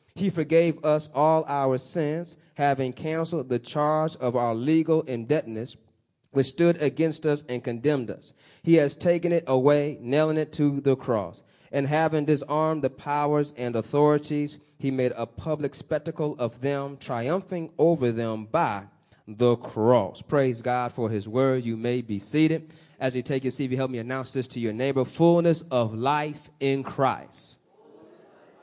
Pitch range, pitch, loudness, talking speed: 125-155 Hz, 140 Hz, -25 LUFS, 160 wpm